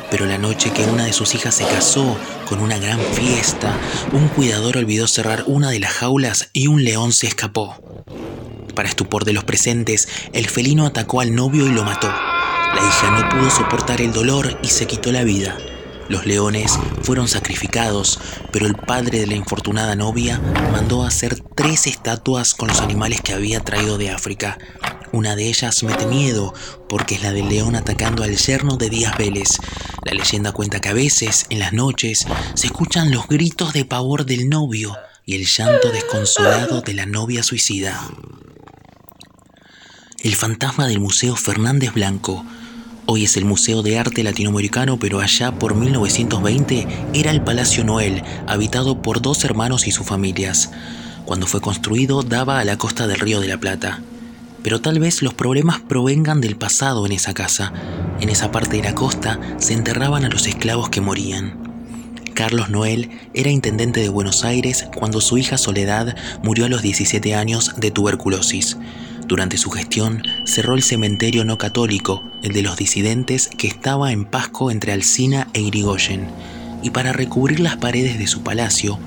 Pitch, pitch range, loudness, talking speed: 115 Hz, 100-125 Hz, -17 LUFS, 170 wpm